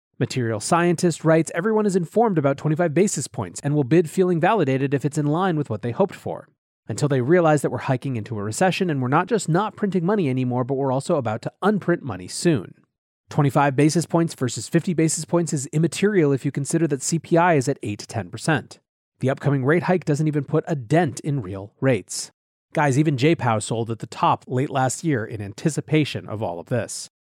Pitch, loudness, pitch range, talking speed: 150 Hz, -22 LUFS, 130-170 Hz, 205 wpm